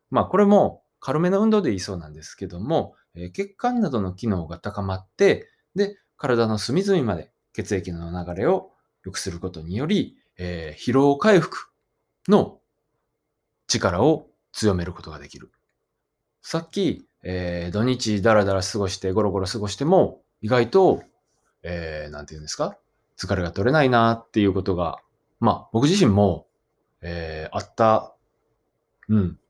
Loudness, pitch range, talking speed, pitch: -23 LUFS, 90-130 Hz, 290 characters per minute, 100 Hz